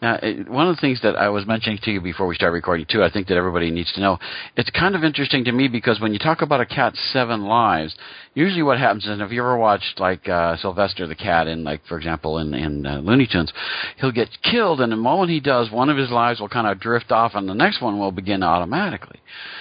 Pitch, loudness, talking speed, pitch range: 110 Hz, -20 LUFS, 255 wpm, 90-125 Hz